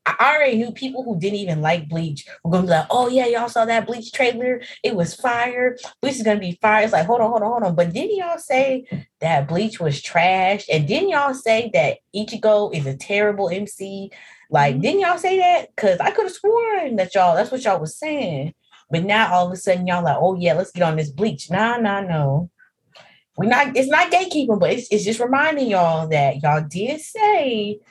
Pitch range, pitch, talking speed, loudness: 175-255 Hz, 210 Hz, 225 wpm, -19 LUFS